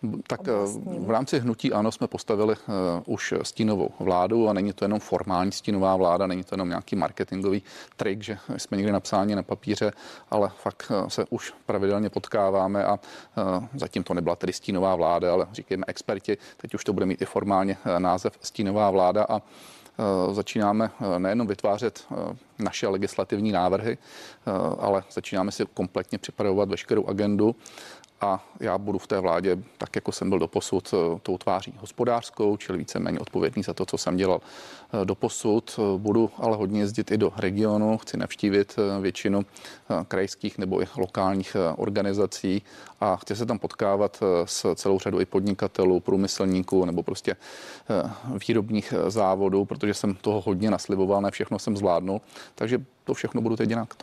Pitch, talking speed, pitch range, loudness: 100 Hz, 155 wpm, 95-105 Hz, -26 LUFS